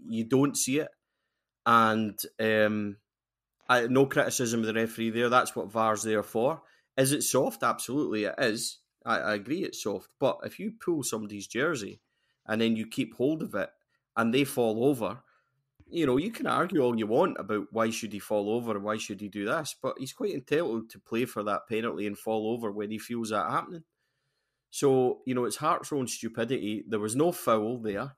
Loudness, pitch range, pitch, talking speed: -29 LUFS, 110-125 Hz, 115 Hz, 200 wpm